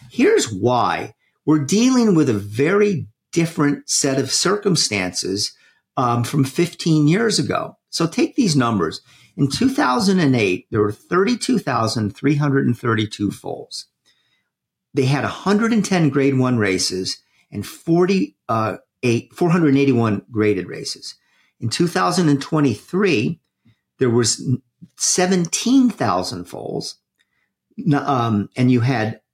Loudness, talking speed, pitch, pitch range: -19 LUFS, 95 wpm, 140 Hz, 115-180 Hz